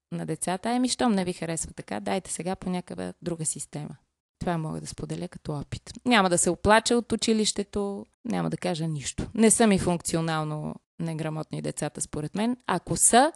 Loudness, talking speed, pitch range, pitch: -26 LUFS, 180 wpm, 155-215 Hz, 175 Hz